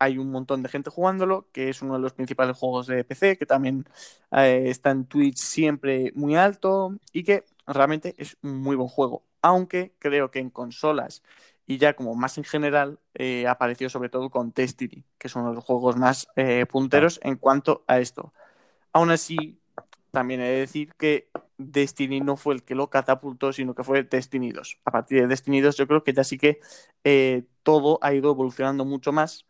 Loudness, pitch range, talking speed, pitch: -24 LUFS, 130-150 Hz, 200 wpm, 135 Hz